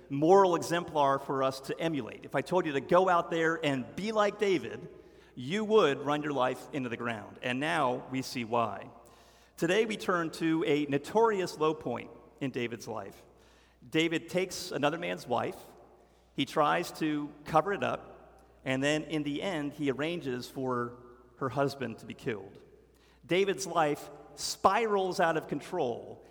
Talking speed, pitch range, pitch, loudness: 165 wpm, 130-175 Hz, 150 Hz, -31 LUFS